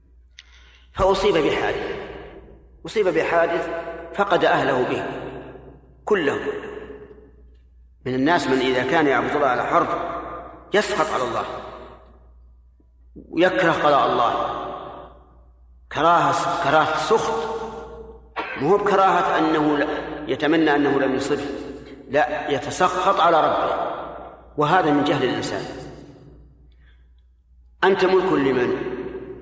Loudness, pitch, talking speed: -21 LUFS, 150 Hz, 90 wpm